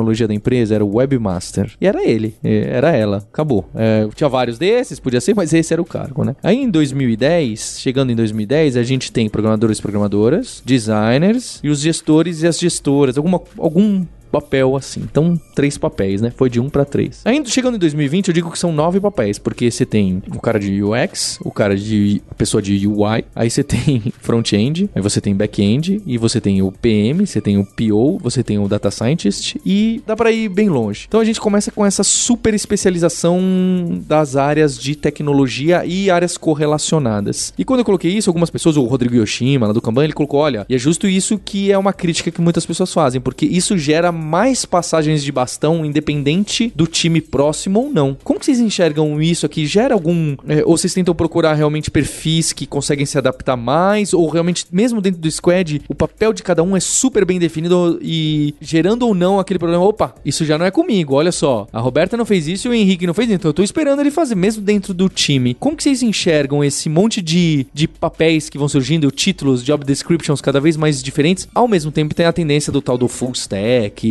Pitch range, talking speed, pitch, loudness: 125-185 Hz, 215 wpm, 155 Hz, -16 LUFS